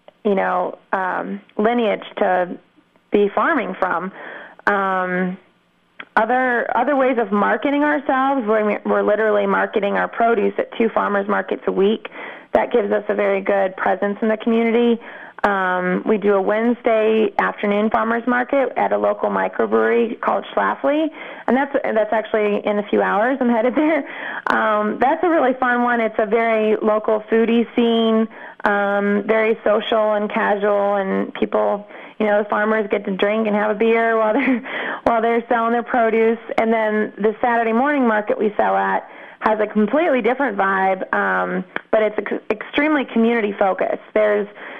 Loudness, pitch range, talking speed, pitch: -19 LUFS, 205-235 Hz, 160 wpm, 220 Hz